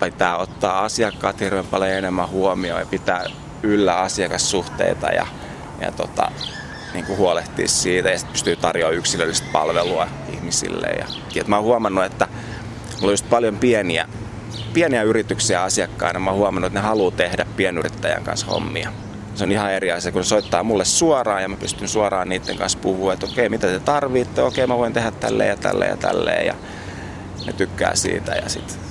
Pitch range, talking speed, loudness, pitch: 95-115 Hz, 180 wpm, -20 LUFS, 100 Hz